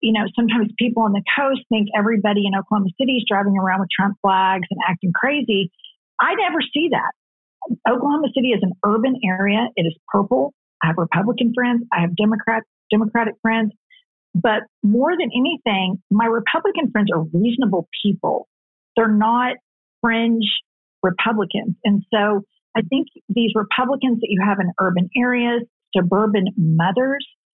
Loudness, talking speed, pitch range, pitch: -19 LUFS, 155 wpm, 195-245 Hz, 220 Hz